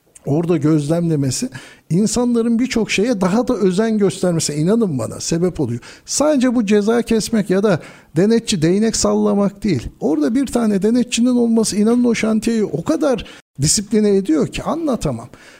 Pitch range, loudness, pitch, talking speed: 175-230 Hz, -17 LUFS, 210 Hz, 140 wpm